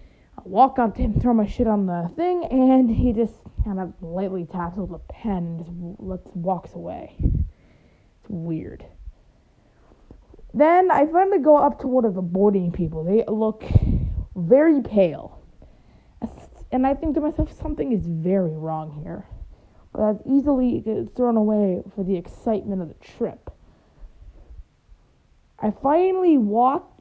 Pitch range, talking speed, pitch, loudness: 180-260 Hz, 145 wpm, 215 Hz, -22 LUFS